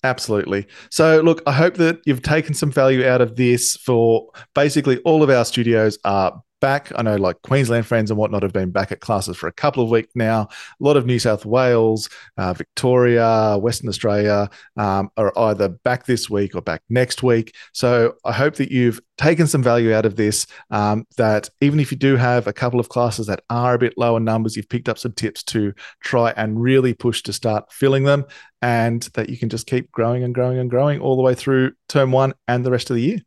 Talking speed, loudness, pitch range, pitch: 225 wpm, -18 LUFS, 110-130 Hz, 120 Hz